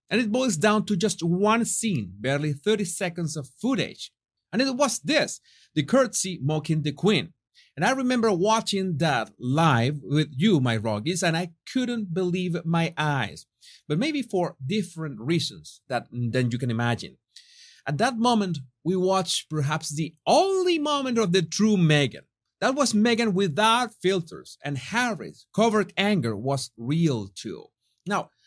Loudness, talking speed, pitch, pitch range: -25 LUFS, 155 wpm, 180 Hz, 150-220 Hz